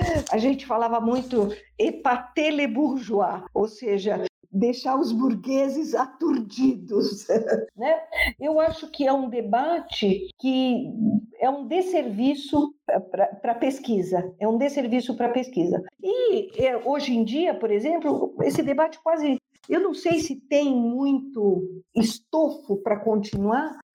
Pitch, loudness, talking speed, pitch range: 265 Hz, -24 LUFS, 130 wpm, 225-310 Hz